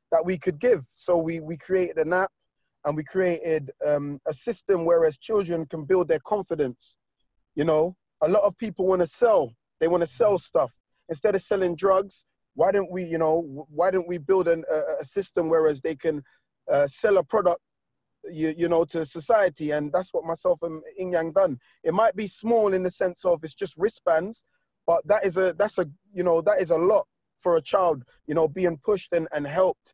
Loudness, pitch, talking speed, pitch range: -25 LUFS, 175 Hz, 210 wpm, 160-190 Hz